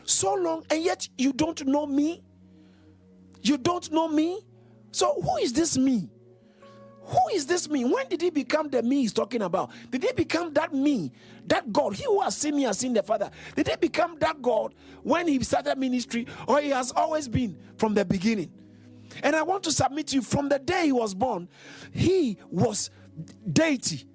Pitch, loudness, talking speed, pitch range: 280 Hz, -26 LUFS, 195 wpm, 210-320 Hz